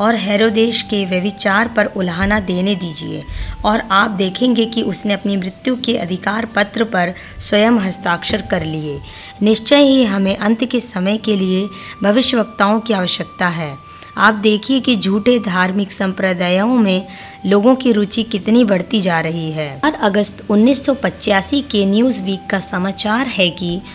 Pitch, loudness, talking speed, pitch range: 200 Hz, -15 LUFS, 150 wpm, 185-225 Hz